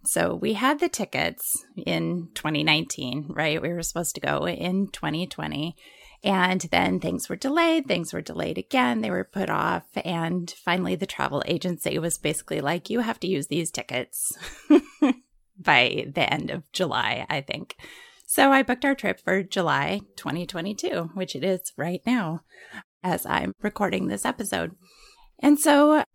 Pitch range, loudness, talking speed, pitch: 165-255 Hz, -25 LUFS, 160 wpm, 185 Hz